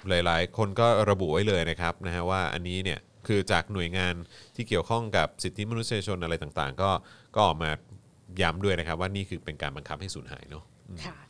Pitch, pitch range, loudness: 95 Hz, 85-100 Hz, -28 LUFS